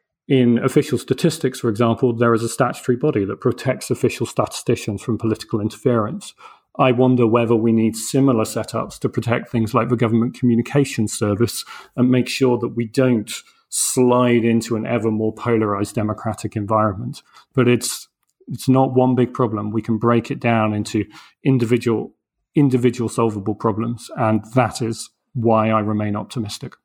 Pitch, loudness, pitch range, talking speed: 120 Hz, -19 LUFS, 110-125 Hz, 155 wpm